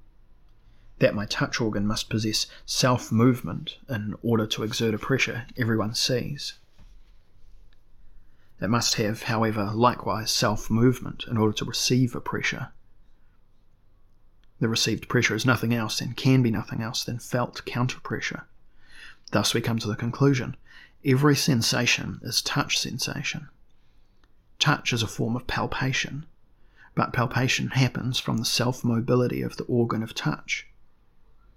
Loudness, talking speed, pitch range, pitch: -25 LUFS, 140 wpm, 105-125 Hz, 115 Hz